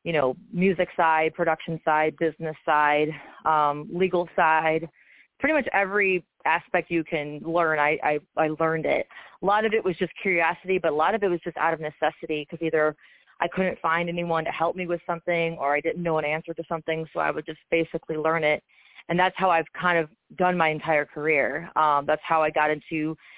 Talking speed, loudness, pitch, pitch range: 210 wpm, -25 LUFS, 165 Hz, 155-175 Hz